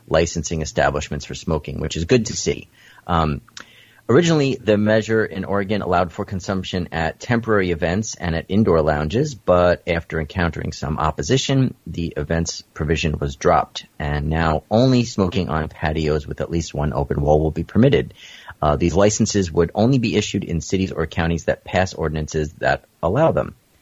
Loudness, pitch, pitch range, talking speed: -20 LUFS, 85 Hz, 80-105 Hz, 170 wpm